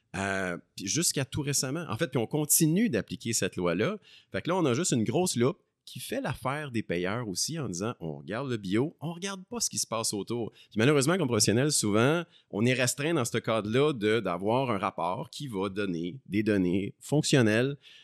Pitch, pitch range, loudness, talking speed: 120 Hz, 100-150 Hz, -29 LUFS, 215 wpm